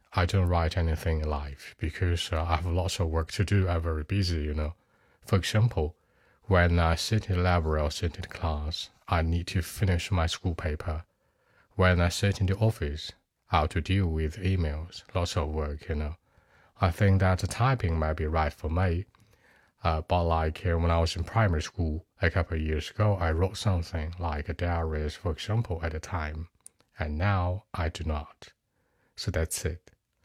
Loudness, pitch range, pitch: -29 LUFS, 80-95 Hz, 85 Hz